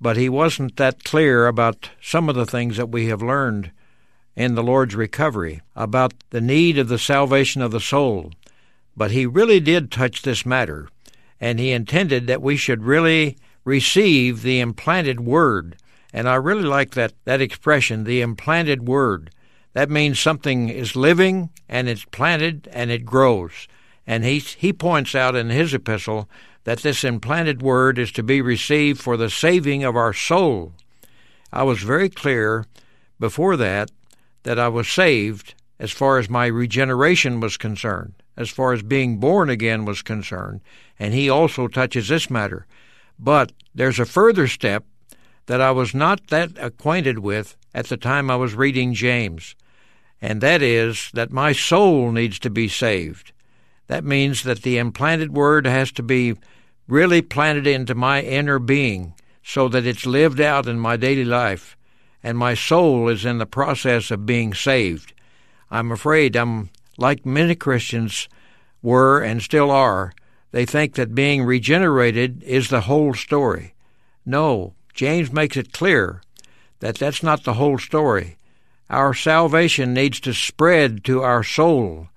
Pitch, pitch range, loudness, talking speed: 125 Hz, 115-140 Hz, -19 LUFS, 160 wpm